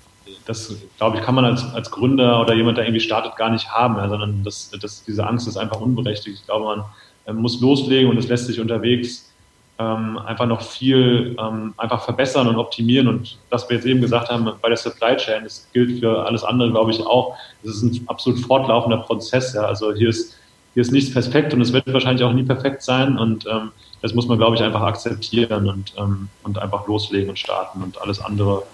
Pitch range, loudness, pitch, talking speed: 105-125 Hz, -19 LUFS, 115 Hz, 220 wpm